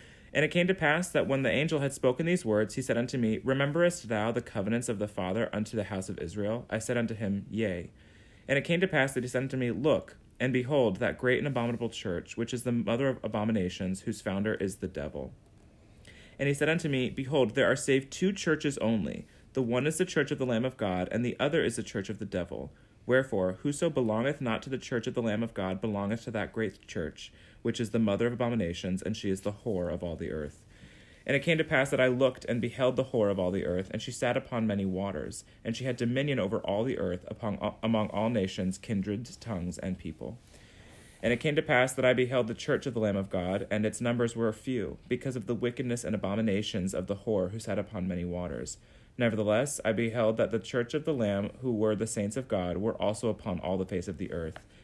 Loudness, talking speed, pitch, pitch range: -31 LUFS, 240 wpm, 115 Hz, 100-130 Hz